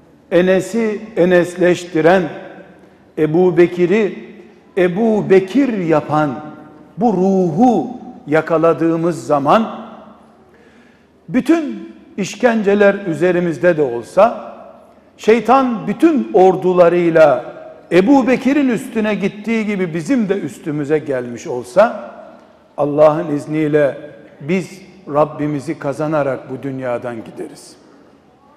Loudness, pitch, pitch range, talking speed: -15 LUFS, 180 Hz, 155-210 Hz, 80 wpm